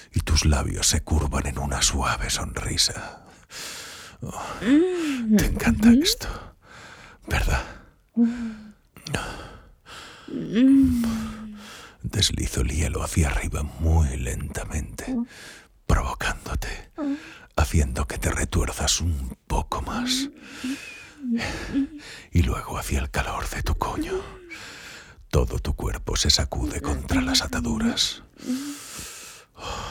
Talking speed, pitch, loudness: 90 wpm, 110 Hz, -25 LUFS